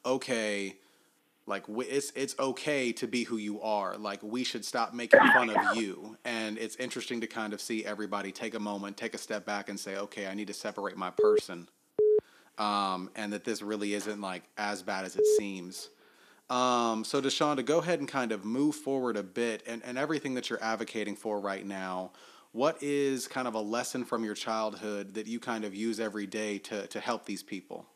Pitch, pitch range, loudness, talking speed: 110 Hz, 105-125 Hz, -32 LUFS, 210 wpm